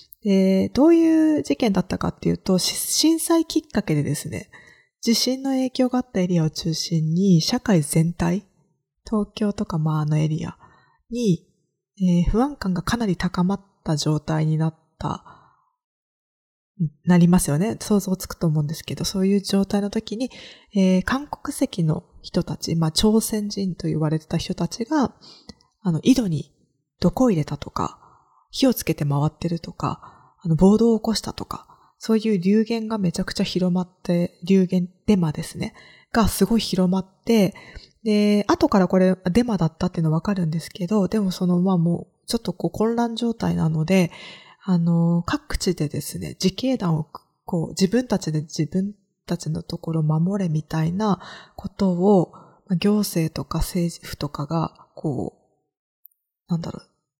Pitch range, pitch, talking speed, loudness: 165-215 Hz, 185 Hz, 305 characters per minute, -22 LUFS